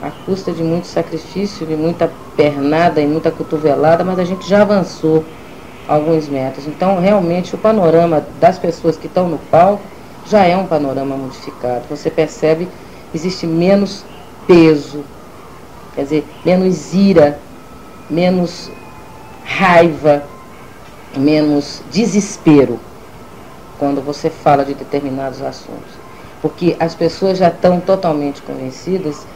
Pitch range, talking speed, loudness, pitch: 145-180 Hz, 120 wpm, -14 LUFS, 160 Hz